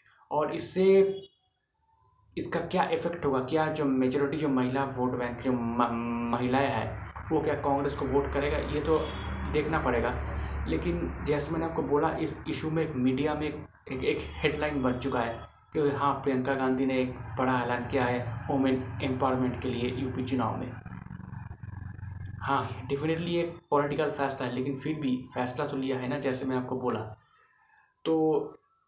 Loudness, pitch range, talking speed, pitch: -29 LUFS, 125-145 Hz, 165 wpm, 130 Hz